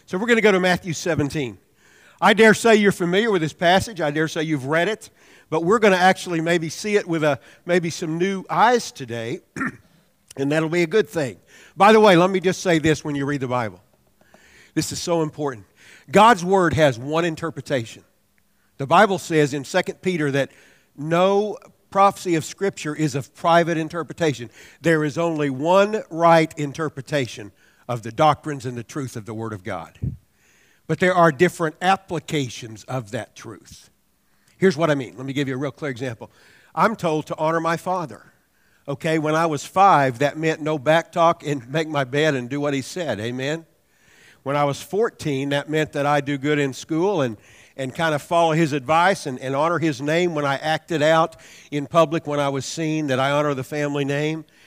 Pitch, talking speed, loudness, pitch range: 155 Hz, 200 wpm, -21 LUFS, 140-170 Hz